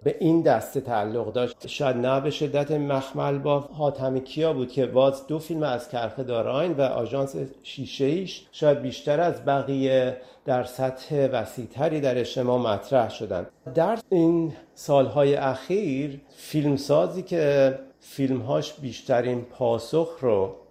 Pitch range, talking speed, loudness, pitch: 130-150 Hz, 135 wpm, -25 LUFS, 135 Hz